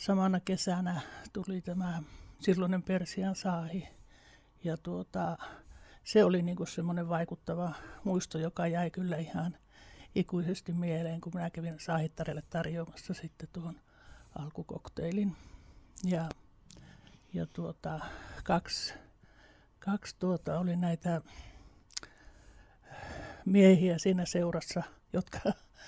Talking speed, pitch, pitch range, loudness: 95 wpm, 170 Hz, 160-185 Hz, -34 LUFS